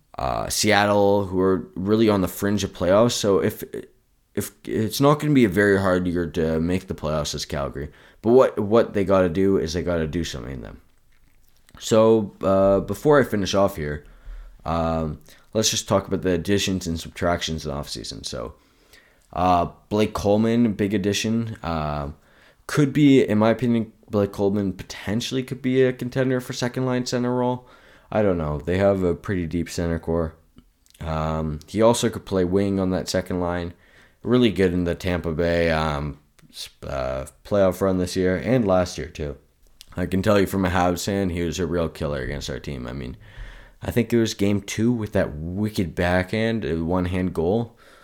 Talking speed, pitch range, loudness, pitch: 190 wpm, 85-110 Hz, -22 LUFS, 95 Hz